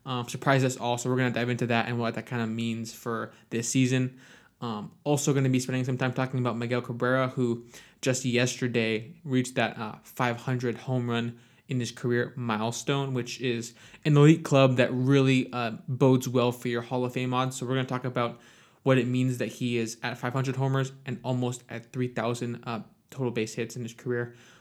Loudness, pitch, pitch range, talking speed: -28 LUFS, 125 Hz, 120-130 Hz, 210 wpm